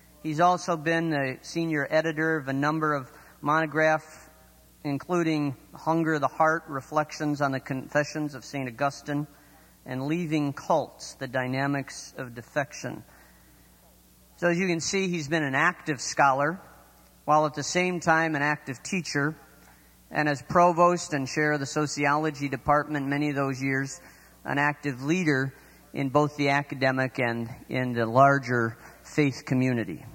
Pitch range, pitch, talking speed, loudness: 135-155 Hz, 145 Hz, 145 wpm, -26 LUFS